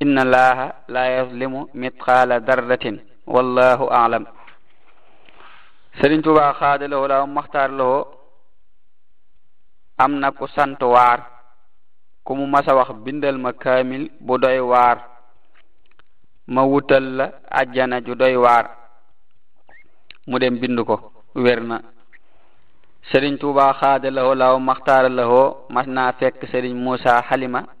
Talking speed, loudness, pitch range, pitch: 95 wpm, -18 LUFS, 125-135 Hz, 130 Hz